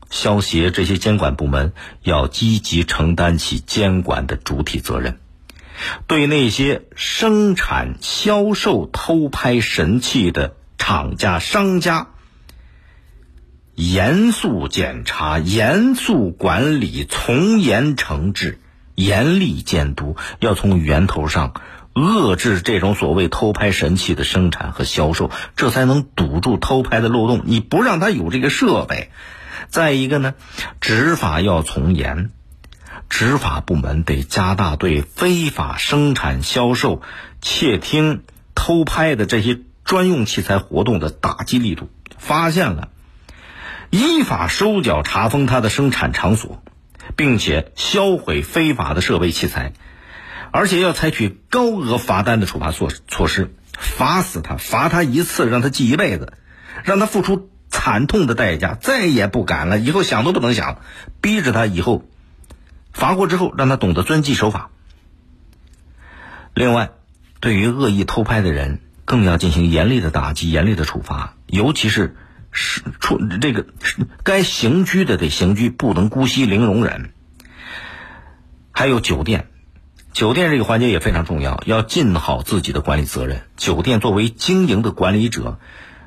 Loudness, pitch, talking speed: -17 LUFS, 95 Hz, 215 characters per minute